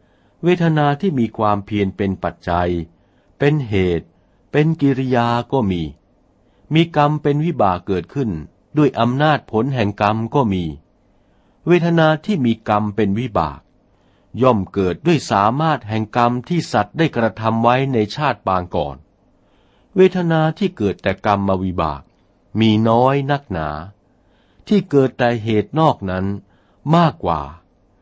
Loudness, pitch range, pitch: -18 LUFS, 95-140 Hz, 110 Hz